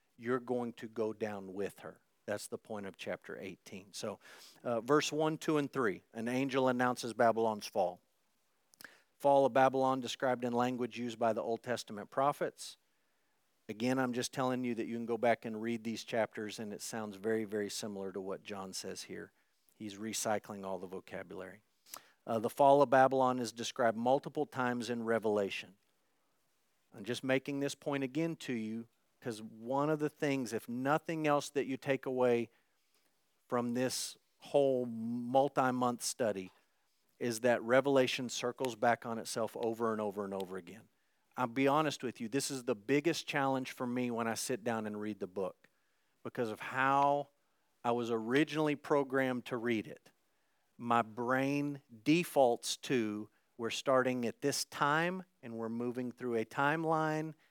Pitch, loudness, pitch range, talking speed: 125 Hz, -35 LUFS, 115-135 Hz, 170 wpm